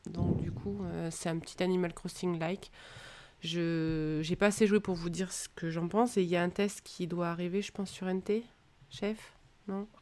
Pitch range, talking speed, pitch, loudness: 170-200 Hz, 220 wpm, 180 Hz, -34 LUFS